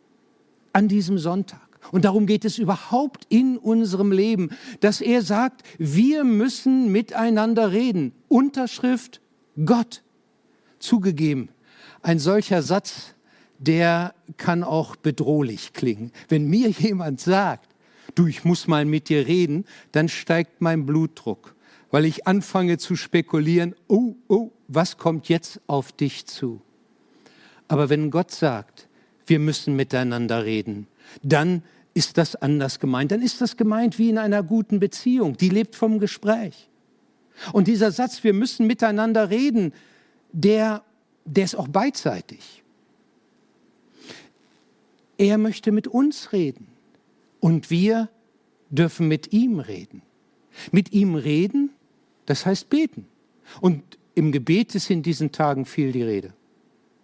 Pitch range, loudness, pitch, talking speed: 155-220 Hz, -22 LUFS, 190 Hz, 130 wpm